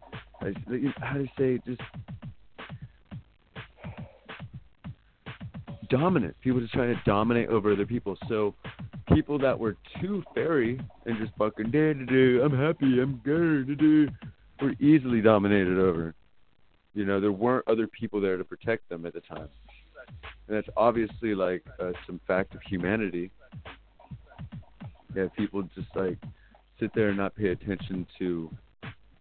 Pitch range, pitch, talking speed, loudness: 95-130 Hz, 110 Hz, 140 wpm, -27 LUFS